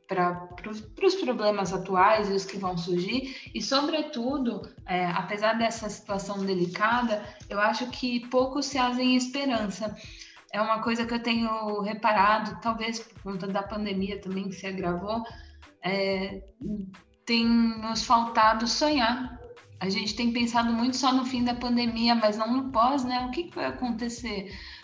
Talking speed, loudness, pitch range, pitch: 155 wpm, -27 LUFS, 195-245 Hz, 220 Hz